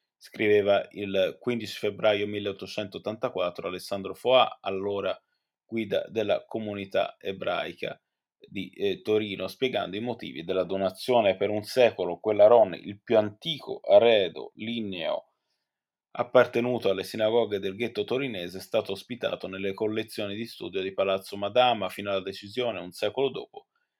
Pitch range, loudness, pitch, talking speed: 95-115 Hz, -27 LUFS, 105 Hz, 130 wpm